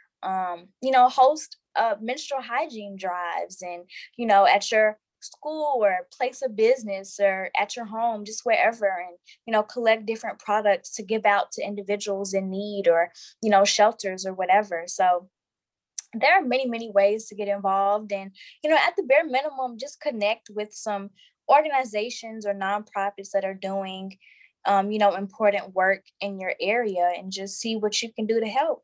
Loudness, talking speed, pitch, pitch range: -24 LUFS, 180 wpm, 210 Hz, 195-235 Hz